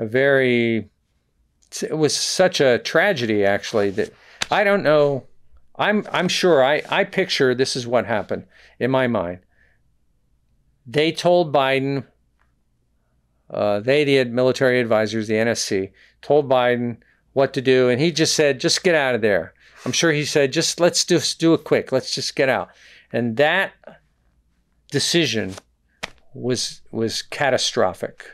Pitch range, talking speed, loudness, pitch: 110-155 Hz, 150 wpm, -19 LUFS, 130 Hz